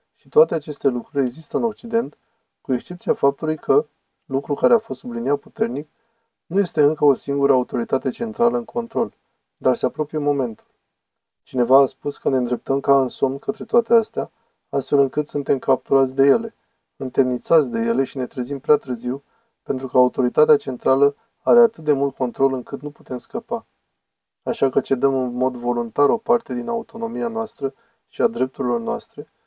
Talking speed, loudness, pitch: 170 wpm, -21 LUFS, 145 Hz